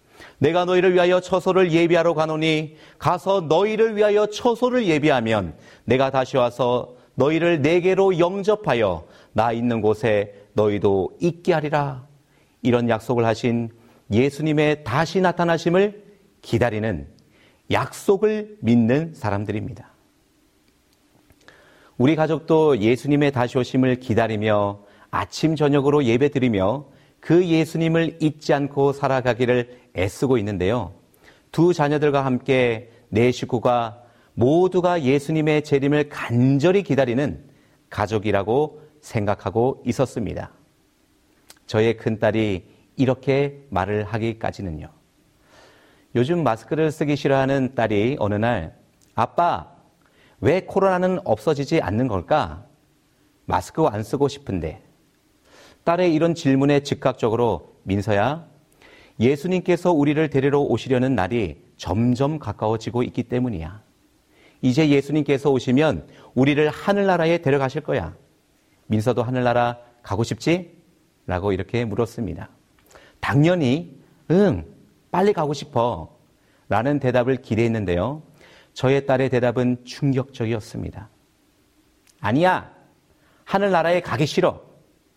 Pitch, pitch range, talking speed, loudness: 135 Hz, 115-155 Hz, 270 characters per minute, -21 LUFS